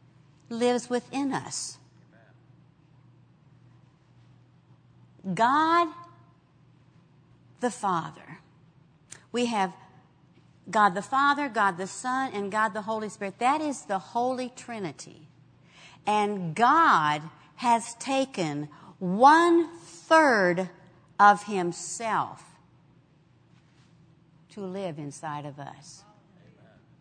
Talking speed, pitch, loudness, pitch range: 80 wpm, 190 Hz, -26 LUFS, 150-235 Hz